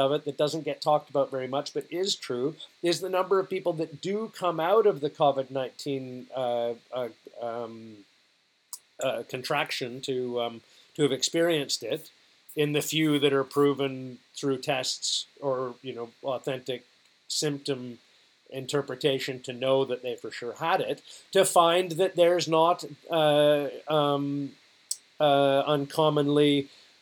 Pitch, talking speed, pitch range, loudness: 140 Hz, 150 wpm, 130-155 Hz, -27 LUFS